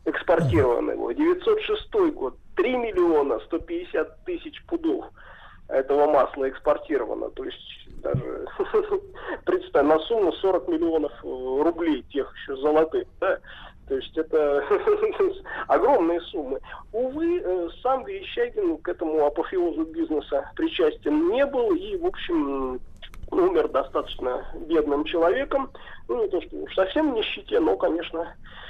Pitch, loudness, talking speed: 340 Hz, -25 LUFS, 115 wpm